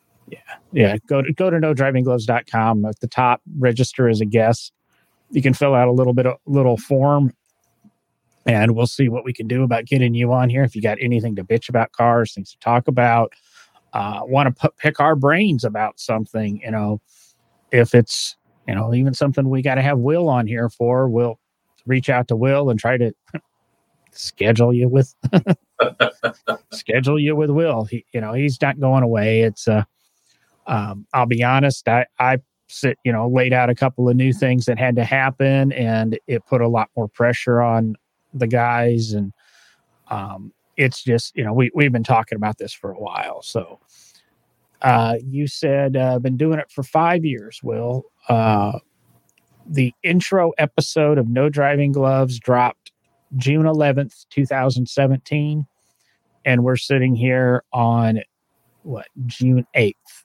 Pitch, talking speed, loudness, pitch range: 125 Hz, 175 wpm, -18 LUFS, 115-140 Hz